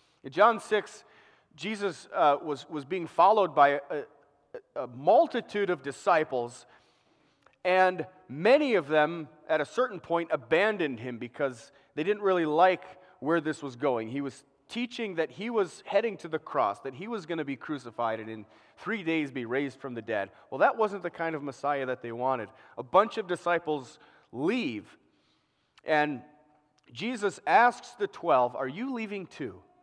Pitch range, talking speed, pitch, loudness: 140-200 Hz, 170 wpm, 160 Hz, -29 LUFS